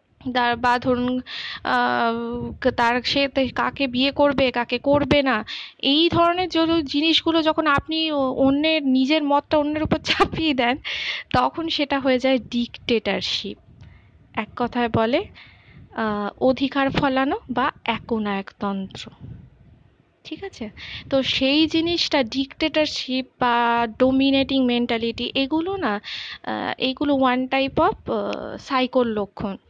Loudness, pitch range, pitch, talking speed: -21 LUFS, 240-295 Hz, 265 Hz, 105 wpm